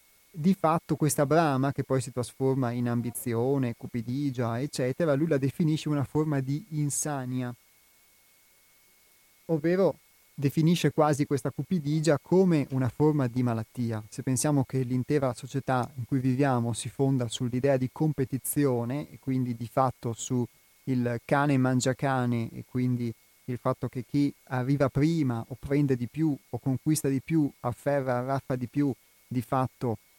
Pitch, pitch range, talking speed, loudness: 135 Hz, 125-145 Hz, 145 wpm, -28 LUFS